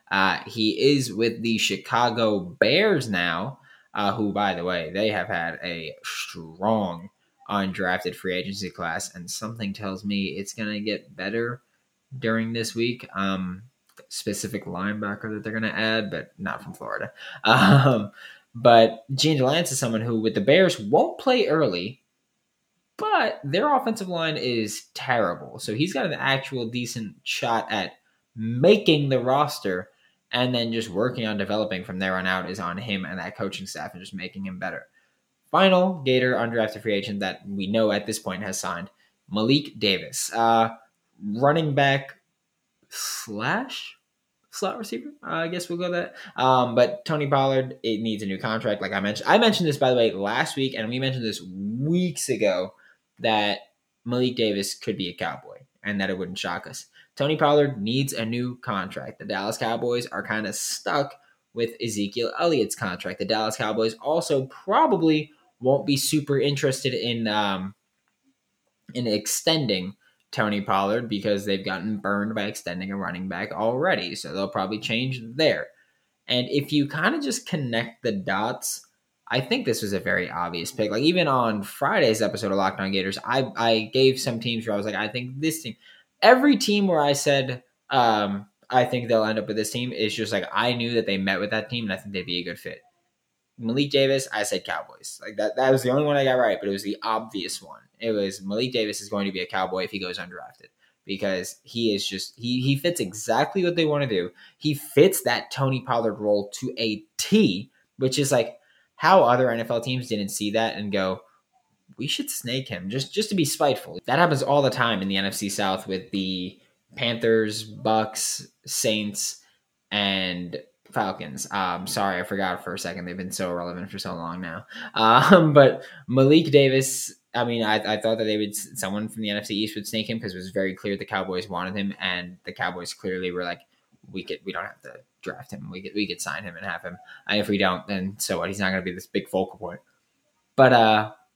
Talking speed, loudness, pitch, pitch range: 195 wpm, -24 LUFS, 110 Hz, 100-130 Hz